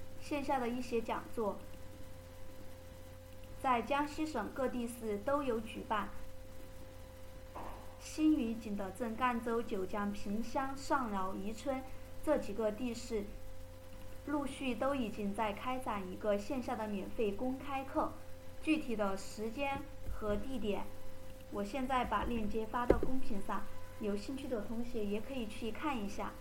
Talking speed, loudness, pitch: 200 characters per minute, -38 LUFS, 220 Hz